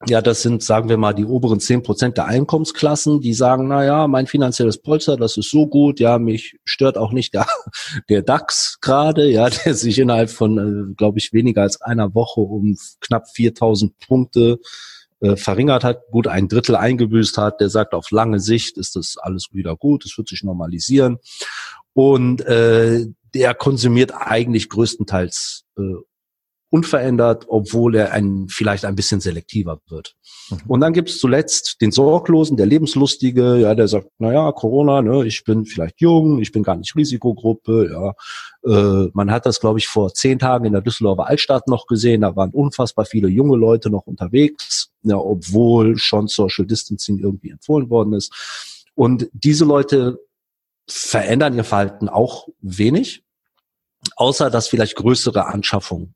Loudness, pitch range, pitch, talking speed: -16 LUFS, 105-130 Hz, 115 Hz, 165 wpm